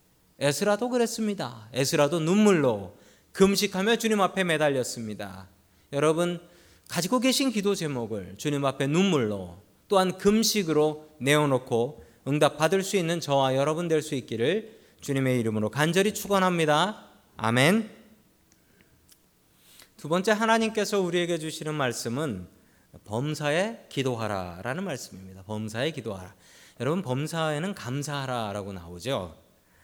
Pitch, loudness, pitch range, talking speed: 145 Hz, -26 LUFS, 110-185 Hz, 300 characters per minute